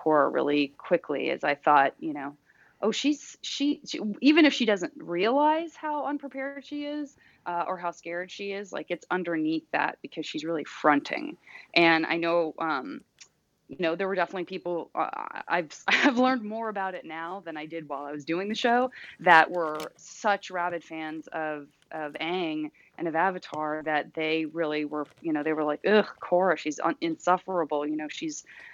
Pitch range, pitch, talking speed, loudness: 160-255 Hz, 175 Hz, 185 wpm, -27 LUFS